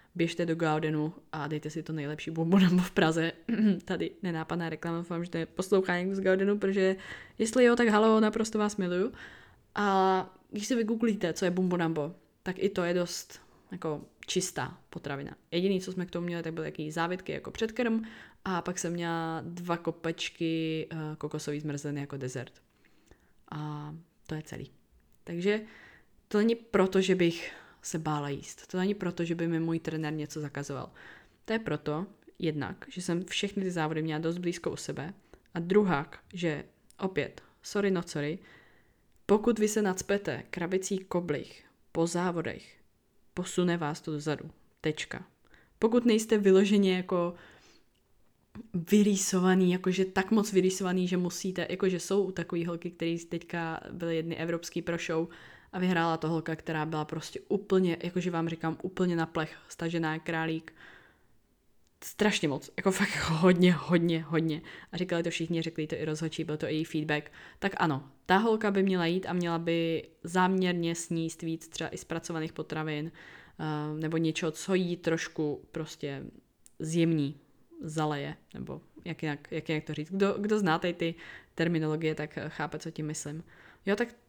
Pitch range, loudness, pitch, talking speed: 160-185 Hz, -31 LUFS, 170 Hz, 160 wpm